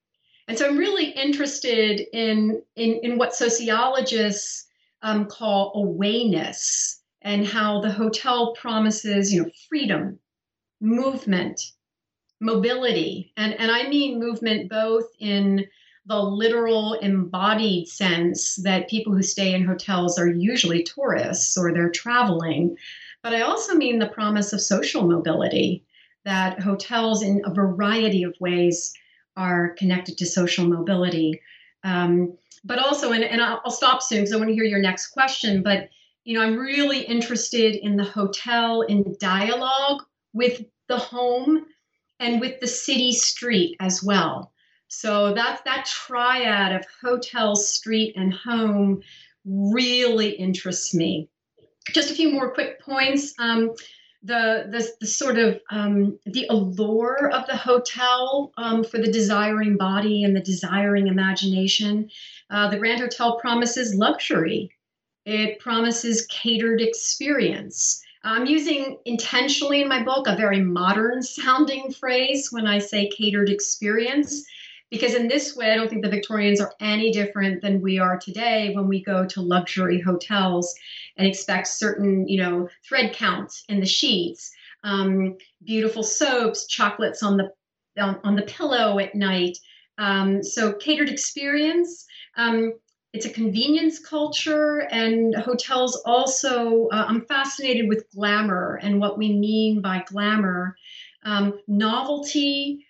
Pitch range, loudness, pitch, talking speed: 195-245 Hz, -22 LUFS, 220 Hz, 140 wpm